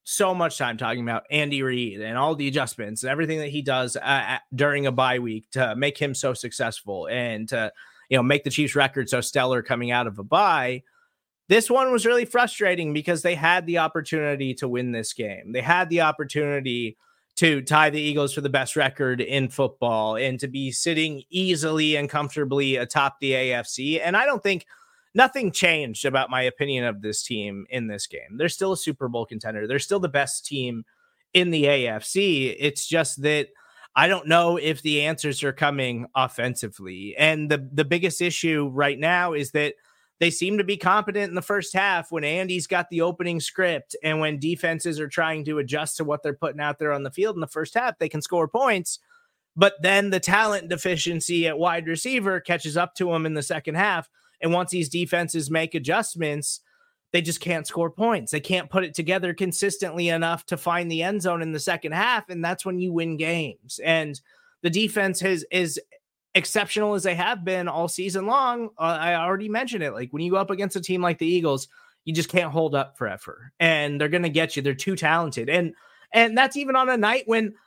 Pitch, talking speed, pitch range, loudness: 160 Hz, 210 wpm, 140-185 Hz, -23 LUFS